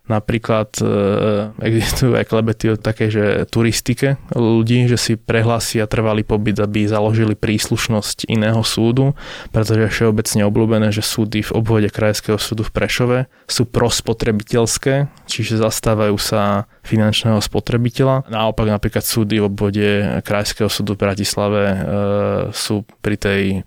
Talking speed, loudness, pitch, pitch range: 130 wpm, -17 LUFS, 110 Hz, 105-115 Hz